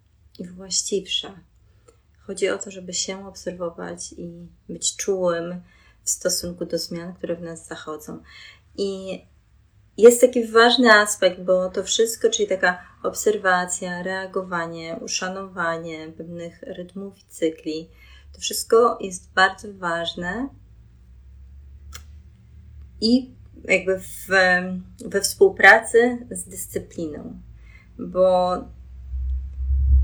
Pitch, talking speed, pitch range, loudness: 180 Hz, 100 wpm, 155-195 Hz, -21 LUFS